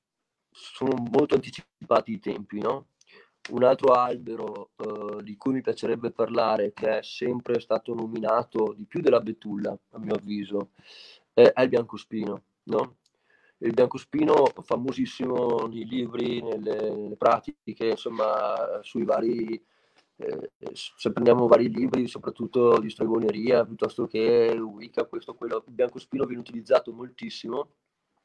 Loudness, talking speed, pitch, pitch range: -26 LUFS, 125 wpm, 120 Hz, 110-135 Hz